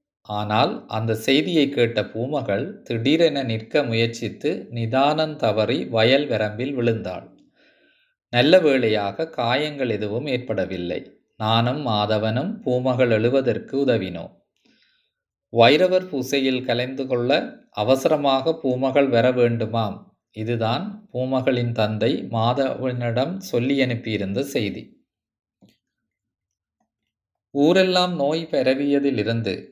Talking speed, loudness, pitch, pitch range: 85 wpm, -21 LUFS, 125 Hz, 110-145 Hz